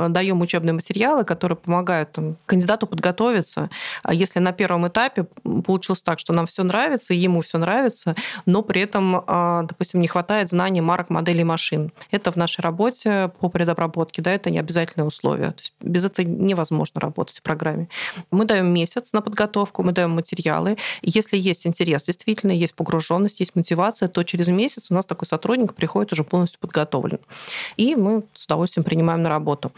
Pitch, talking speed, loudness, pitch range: 180 Hz, 165 wpm, -21 LUFS, 170-200 Hz